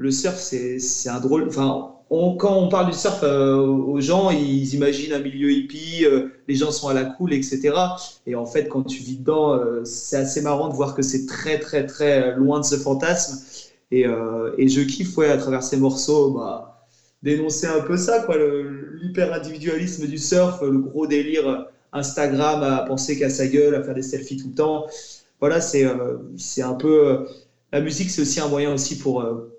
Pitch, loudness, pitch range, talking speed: 145 Hz, -21 LUFS, 135-155 Hz, 205 wpm